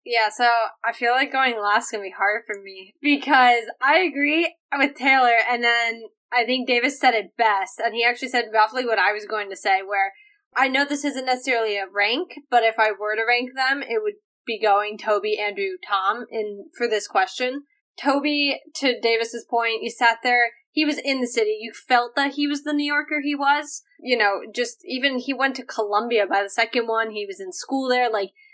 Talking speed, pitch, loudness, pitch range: 215 wpm, 245 Hz, -21 LUFS, 220-280 Hz